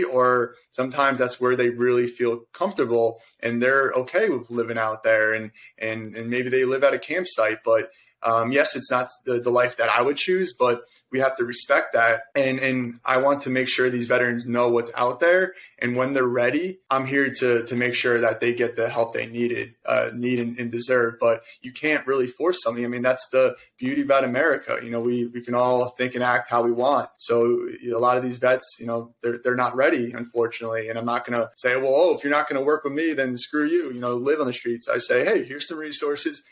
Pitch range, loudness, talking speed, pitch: 120-135 Hz, -23 LUFS, 240 wpm, 125 Hz